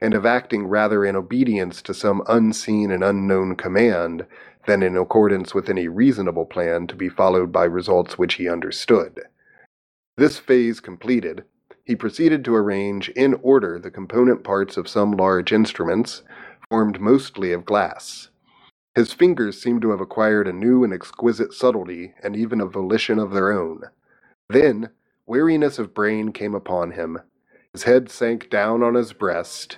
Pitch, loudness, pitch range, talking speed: 105 Hz, -20 LUFS, 95-120 Hz, 160 wpm